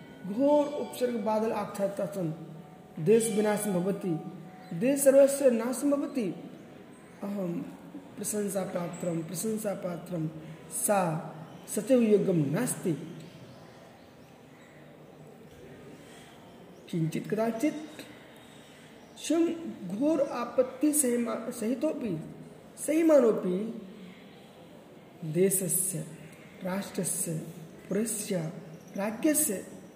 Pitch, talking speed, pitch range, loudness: 200 Hz, 70 wpm, 180-240 Hz, -29 LUFS